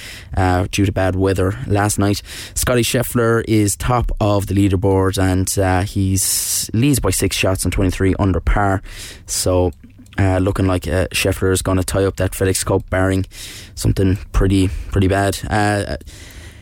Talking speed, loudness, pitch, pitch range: 165 wpm, -17 LUFS, 95 Hz, 95-105 Hz